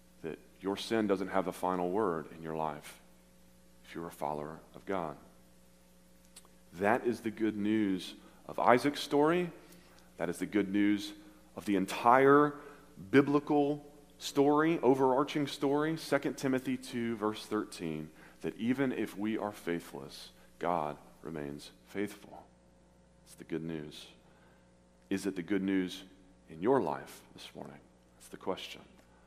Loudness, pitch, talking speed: -33 LUFS, 95 Hz, 135 wpm